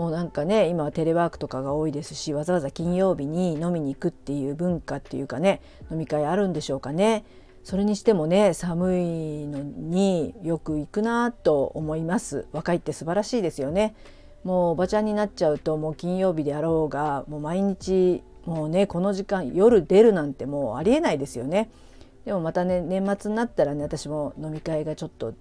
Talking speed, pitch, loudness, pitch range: 395 characters per minute, 170 Hz, -25 LUFS, 150-195 Hz